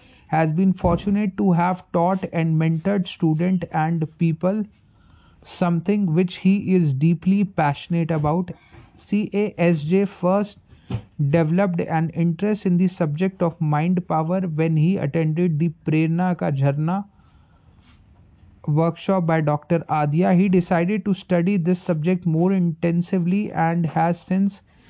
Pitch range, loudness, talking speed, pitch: 160-185 Hz, -21 LUFS, 130 wpm, 170 Hz